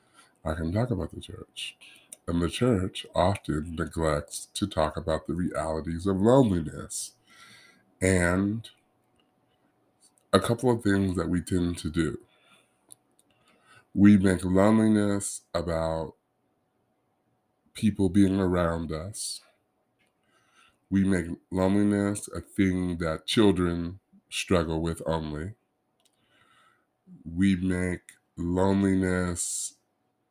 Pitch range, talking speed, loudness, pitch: 85-100 Hz, 95 wpm, -27 LUFS, 90 Hz